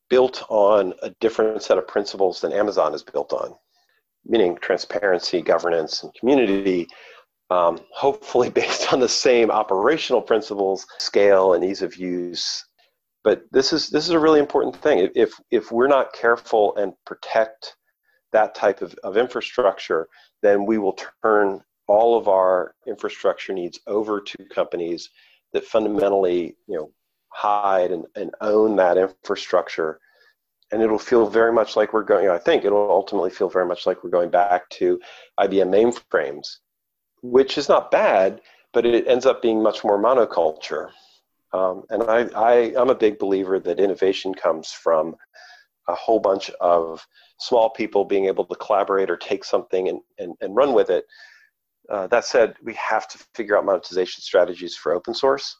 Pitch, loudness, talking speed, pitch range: 110 Hz, -20 LUFS, 165 wpm, 95-150 Hz